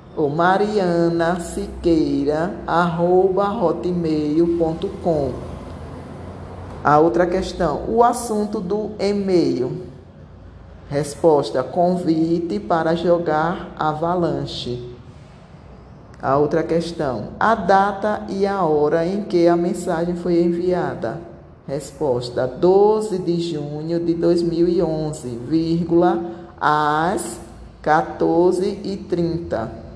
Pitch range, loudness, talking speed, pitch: 155-180 Hz, -20 LUFS, 80 wpm, 170 Hz